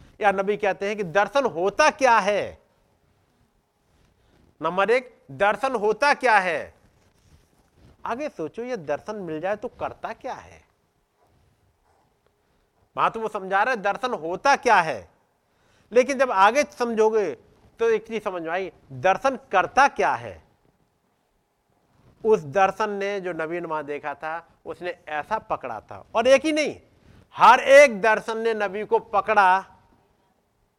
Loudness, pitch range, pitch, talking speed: -22 LUFS, 180-240 Hz, 205 Hz, 135 wpm